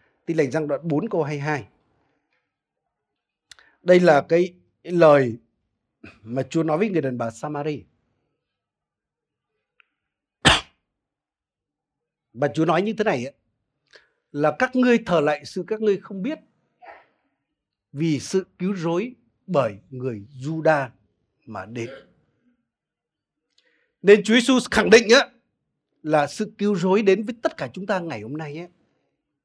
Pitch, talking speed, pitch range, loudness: 160 Hz, 130 wpm, 140-195 Hz, -21 LUFS